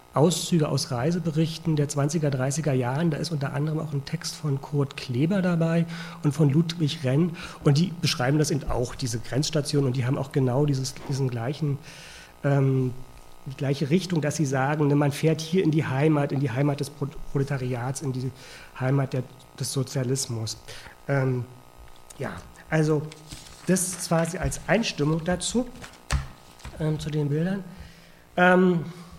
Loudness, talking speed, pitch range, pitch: -26 LUFS, 160 wpm, 135-160 Hz, 145 Hz